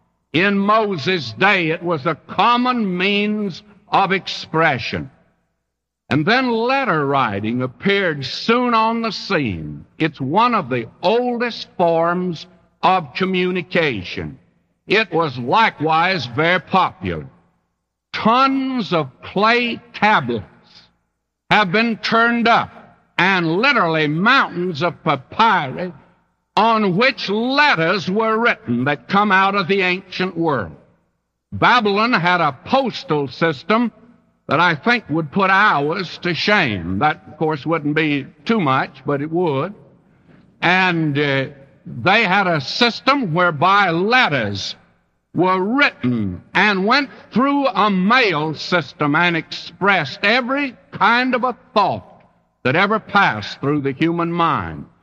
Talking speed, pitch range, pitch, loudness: 120 wpm, 155-220 Hz, 180 Hz, -17 LUFS